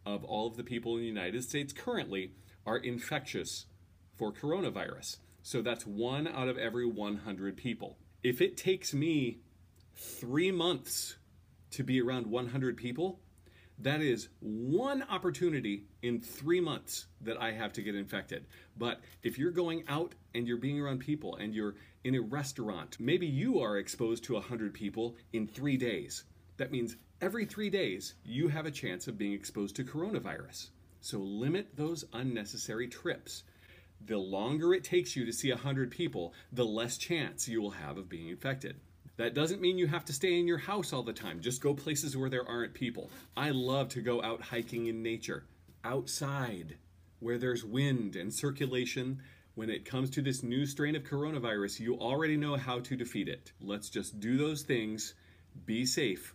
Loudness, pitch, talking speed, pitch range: -36 LUFS, 120 Hz, 175 wpm, 105-140 Hz